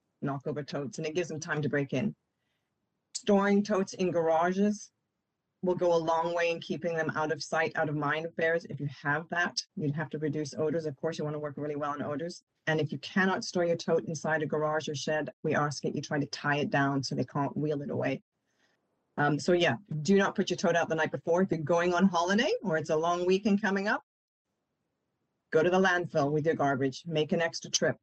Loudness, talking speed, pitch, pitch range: -30 LUFS, 240 wpm, 160 Hz, 150-175 Hz